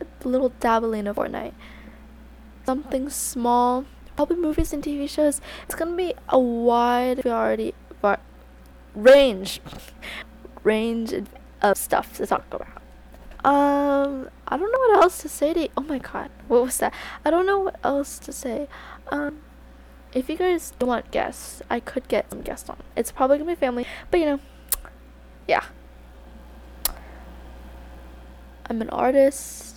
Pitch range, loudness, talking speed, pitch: 205-290 Hz, -23 LUFS, 150 wpm, 255 Hz